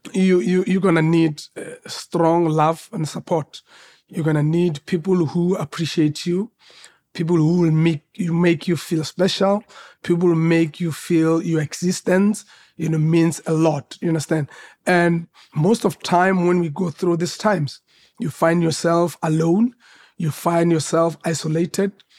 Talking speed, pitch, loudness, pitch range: 155 wpm, 170 Hz, -20 LUFS, 160-185 Hz